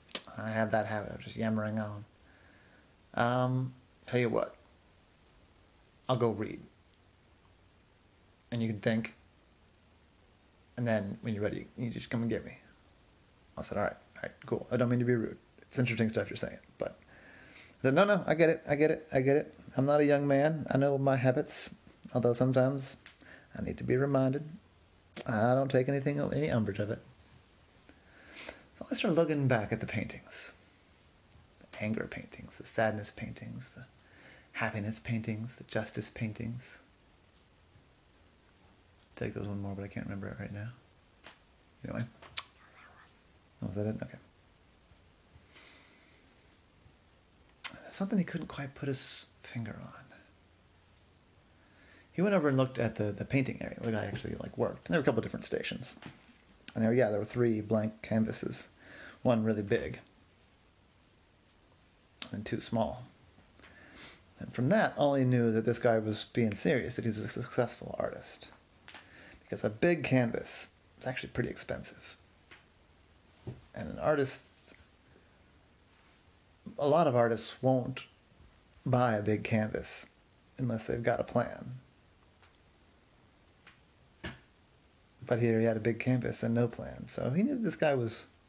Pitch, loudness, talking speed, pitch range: 110 Hz, -33 LUFS, 150 wpm, 95-125 Hz